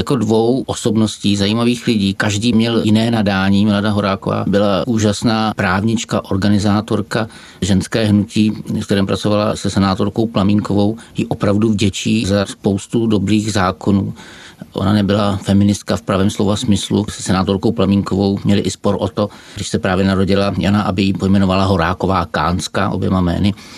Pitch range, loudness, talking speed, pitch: 95-110 Hz, -16 LUFS, 145 wpm, 100 Hz